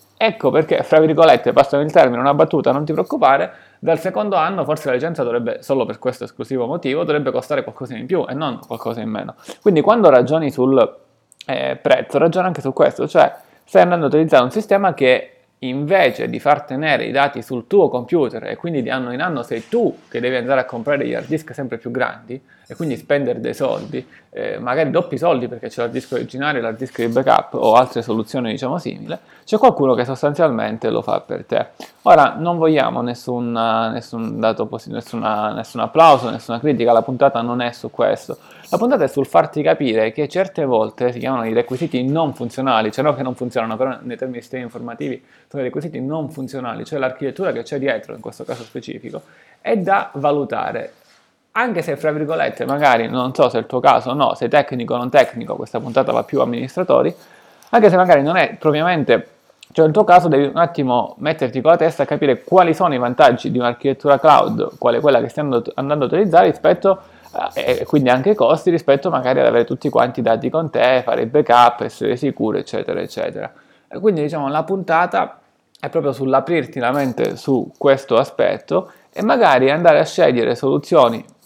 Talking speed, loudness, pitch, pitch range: 200 wpm, -17 LUFS, 135 Hz, 125-160 Hz